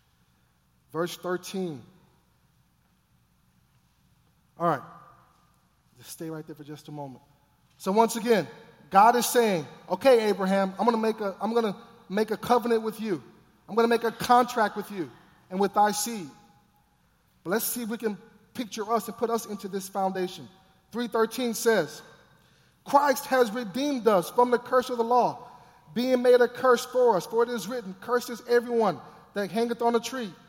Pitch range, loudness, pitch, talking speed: 185-240 Hz, -26 LUFS, 220 Hz, 165 wpm